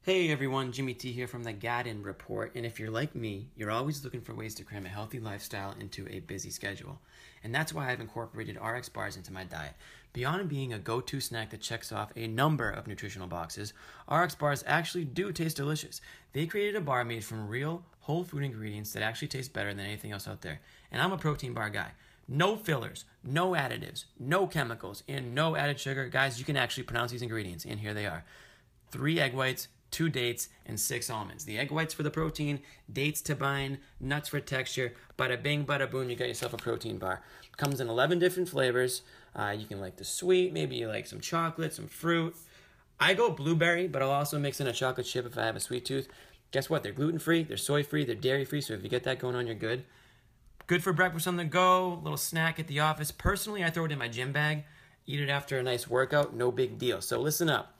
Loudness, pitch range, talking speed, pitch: -32 LUFS, 115-150 Hz, 230 wpm, 130 Hz